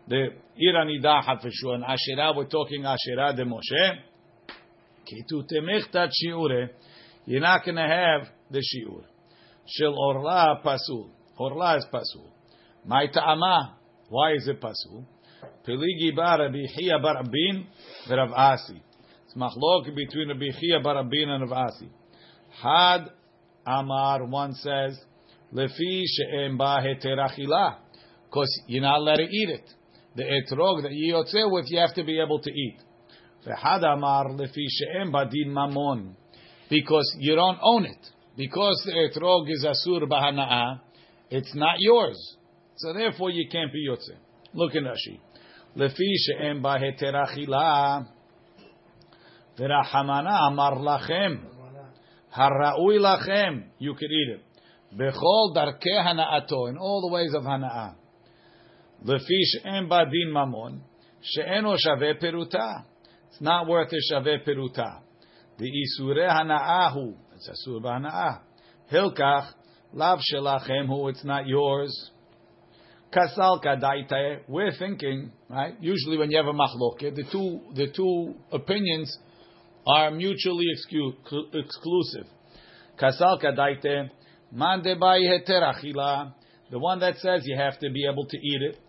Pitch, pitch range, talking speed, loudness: 145 Hz, 135-170 Hz, 120 wpm, -25 LUFS